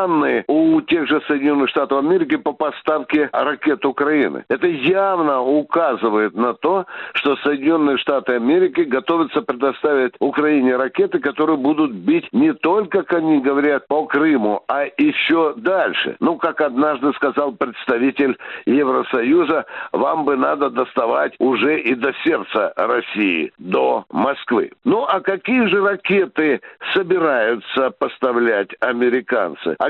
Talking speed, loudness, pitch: 125 wpm, -18 LUFS, 155 Hz